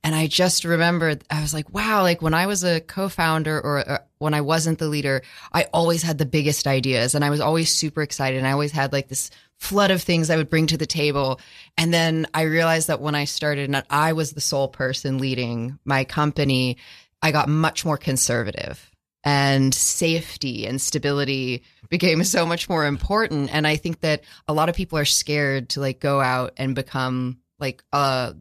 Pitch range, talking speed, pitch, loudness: 135-160 Hz, 205 wpm, 150 Hz, -21 LUFS